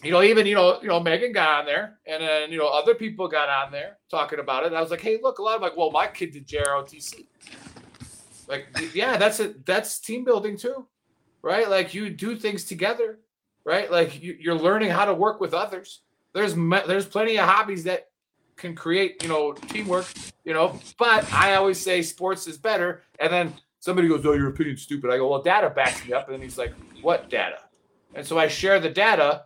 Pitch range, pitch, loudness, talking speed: 155-210 Hz, 180 Hz, -23 LUFS, 225 wpm